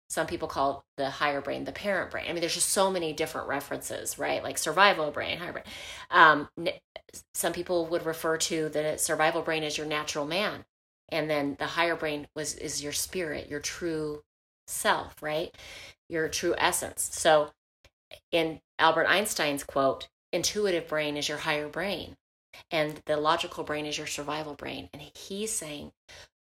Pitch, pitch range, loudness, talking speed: 155 Hz, 150-165 Hz, -28 LUFS, 170 wpm